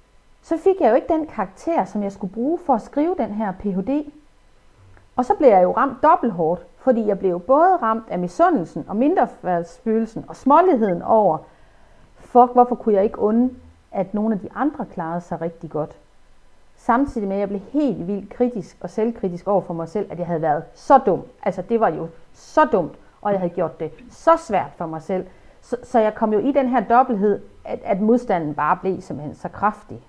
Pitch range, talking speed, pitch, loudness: 175-245 Hz, 210 wpm, 210 Hz, -20 LUFS